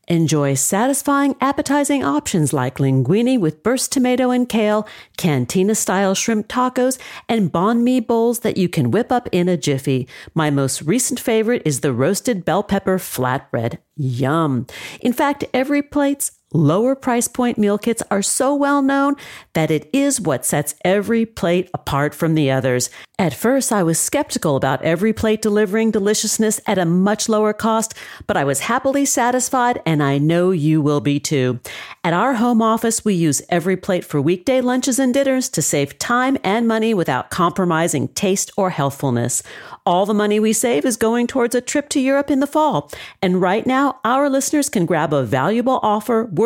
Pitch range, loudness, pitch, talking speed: 160-250 Hz, -18 LUFS, 210 Hz, 175 wpm